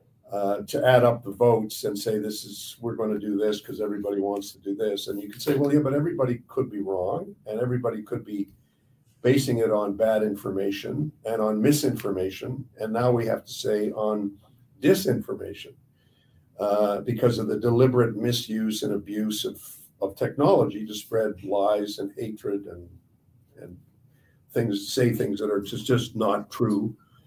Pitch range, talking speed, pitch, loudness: 100-125 Hz, 175 wpm, 110 Hz, -26 LUFS